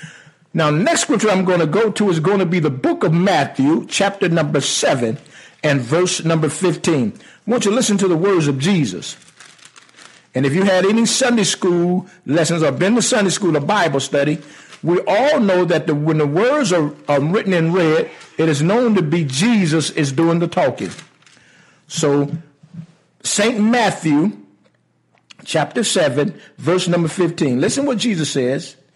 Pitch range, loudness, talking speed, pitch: 155-200 Hz, -17 LUFS, 175 wpm, 170 Hz